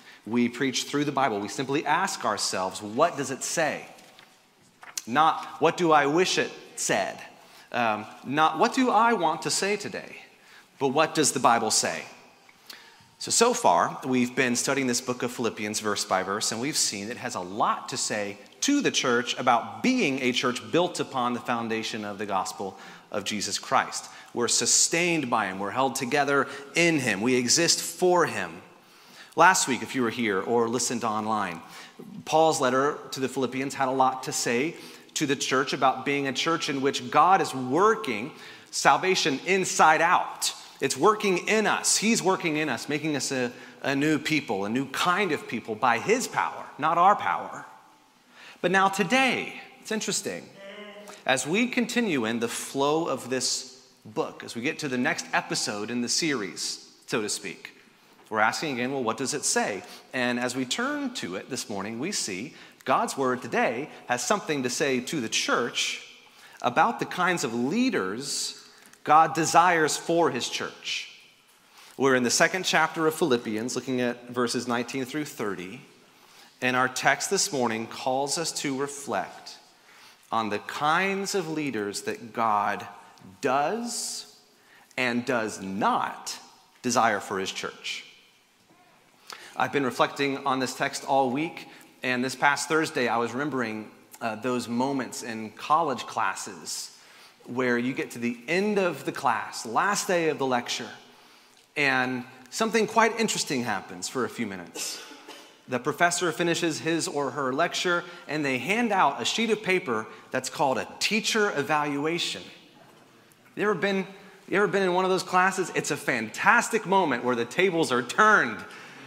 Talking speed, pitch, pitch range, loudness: 165 wpm, 140 Hz, 125-180 Hz, -26 LUFS